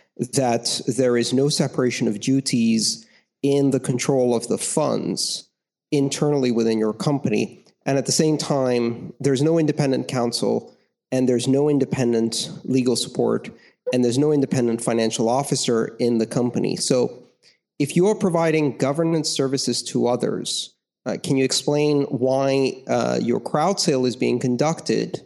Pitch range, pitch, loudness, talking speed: 120-145 Hz, 130 Hz, -21 LUFS, 145 wpm